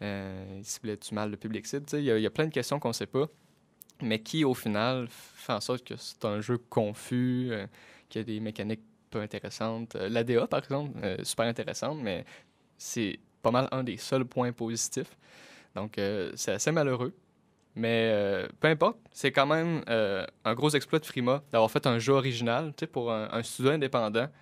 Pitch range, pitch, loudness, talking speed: 110-135 Hz, 120 Hz, -30 LUFS, 205 wpm